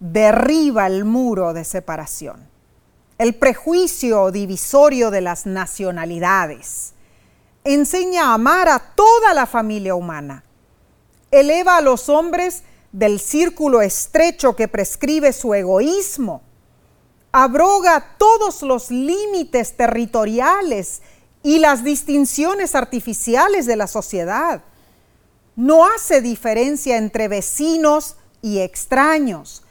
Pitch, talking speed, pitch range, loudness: 255 Hz, 100 wpm, 205-310 Hz, -16 LUFS